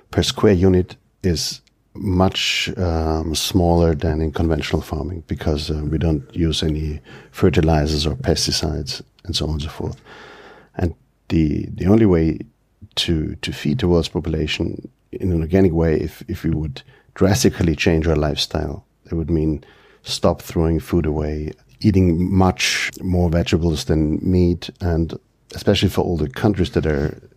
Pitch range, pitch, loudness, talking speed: 80-95 Hz, 85 Hz, -20 LUFS, 155 wpm